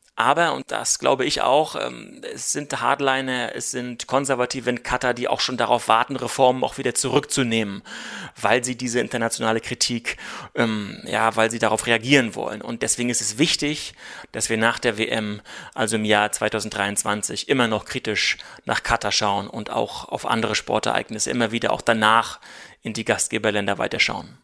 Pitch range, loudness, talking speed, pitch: 110-125 Hz, -22 LUFS, 165 wpm, 115 Hz